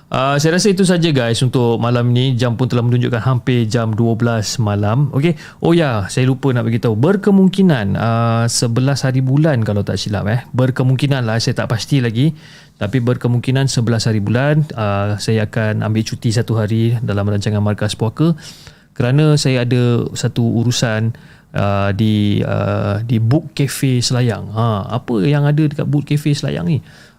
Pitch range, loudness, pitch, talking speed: 110-140 Hz, -16 LUFS, 125 Hz, 170 wpm